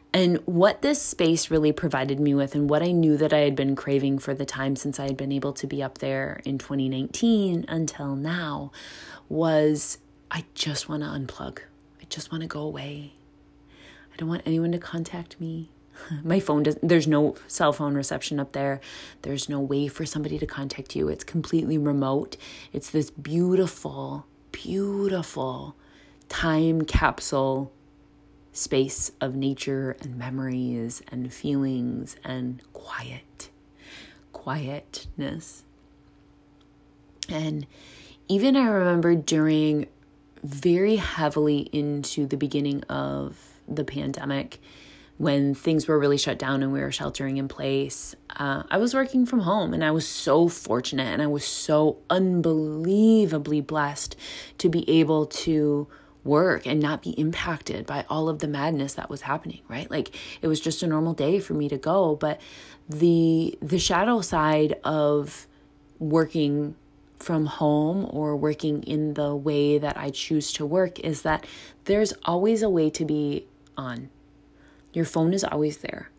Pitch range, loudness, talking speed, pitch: 140-160 Hz, -25 LUFS, 150 wpm, 150 Hz